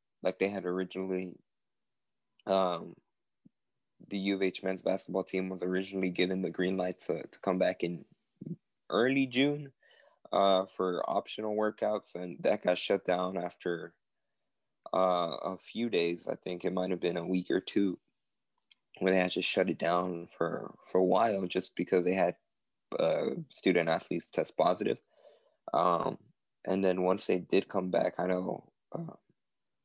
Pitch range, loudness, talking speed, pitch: 90-95 Hz, -32 LUFS, 160 wpm, 95 Hz